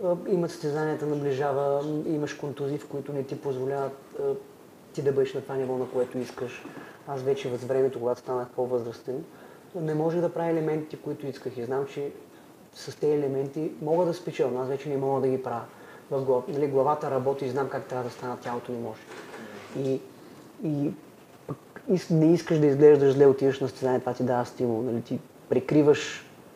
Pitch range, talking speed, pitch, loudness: 130-150 Hz, 180 wpm, 140 Hz, -27 LUFS